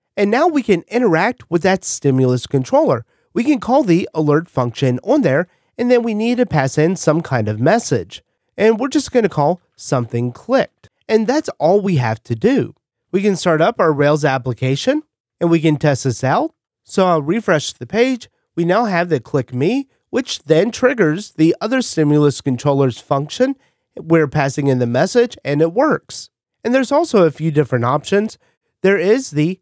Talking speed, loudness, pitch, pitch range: 190 wpm, -16 LUFS, 165 Hz, 140-225 Hz